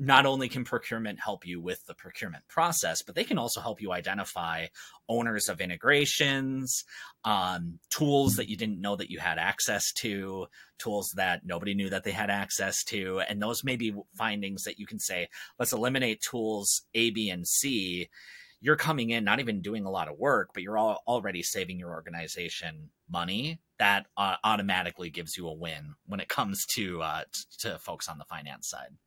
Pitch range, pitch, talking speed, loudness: 90-120 Hz, 105 Hz, 190 wpm, -30 LUFS